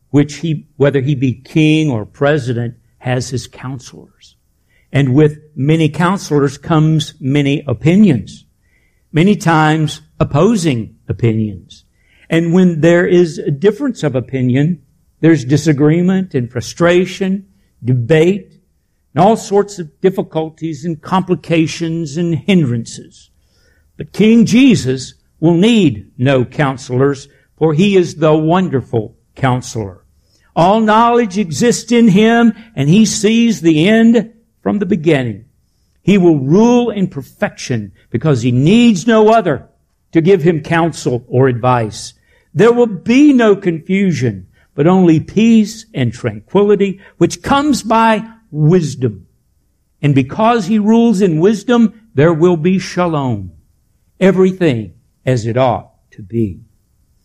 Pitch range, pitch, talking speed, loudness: 130-195 Hz, 160 Hz, 120 wpm, -13 LUFS